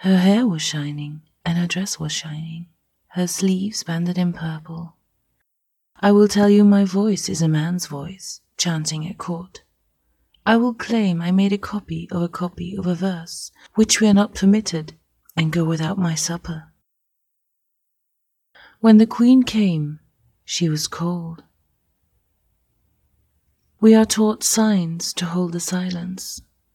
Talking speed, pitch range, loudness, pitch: 145 wpm, 165-200 Hz, -19 LUFS, 175 Hz